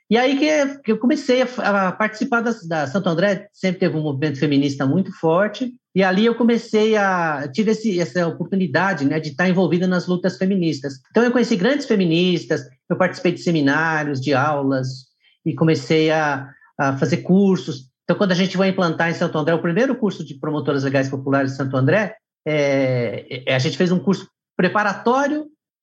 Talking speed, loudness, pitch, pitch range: 180 wpm, -19 LUFS, 180 Hz, 150-205 Hz